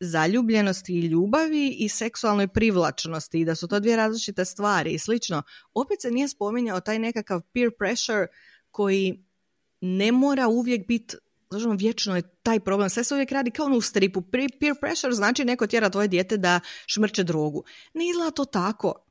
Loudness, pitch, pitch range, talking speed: -24 LUFS, 215 Hz, 190-240 Hz, 175 wpm